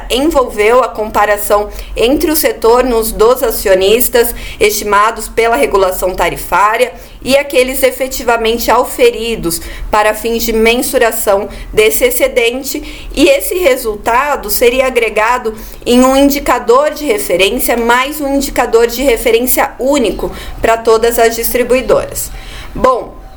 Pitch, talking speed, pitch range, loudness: 250 Hz, 110 wpm, 225-300 Hz, -11 LUFS